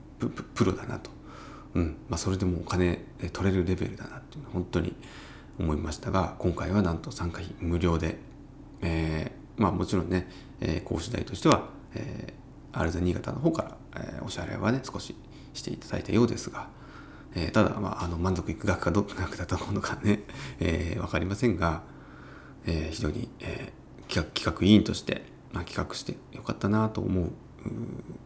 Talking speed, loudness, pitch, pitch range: 345 characters per minute, -30 LUFS, 95 Hz, 85-110 Hz